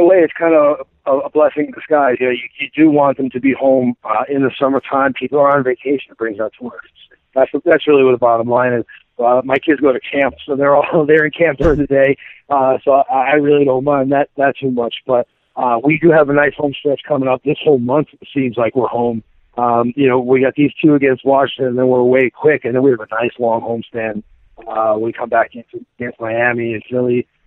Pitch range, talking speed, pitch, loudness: 120-145 Hz, 255 wpm, 135 Hz, -14 LUFS